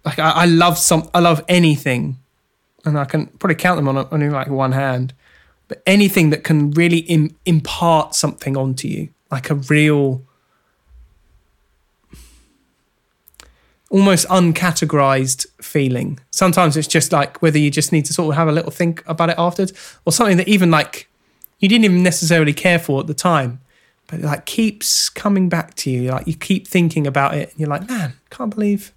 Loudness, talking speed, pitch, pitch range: -16 LUFS, 180 wpm, 155 Hz, 140-175 Hz